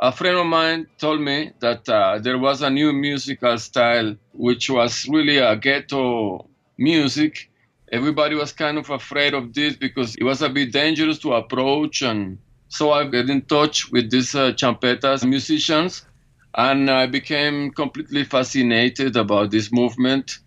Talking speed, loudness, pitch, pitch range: 160 wpm, -19 LUFS, 135 Hz, 125-150 Hz